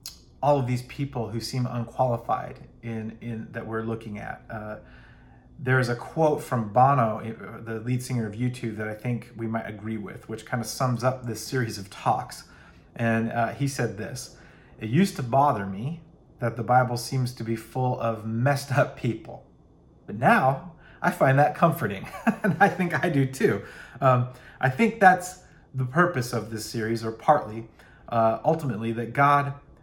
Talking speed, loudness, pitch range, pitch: 180 wpm, -26 LUFS, 115-140 Hz, 125 Hz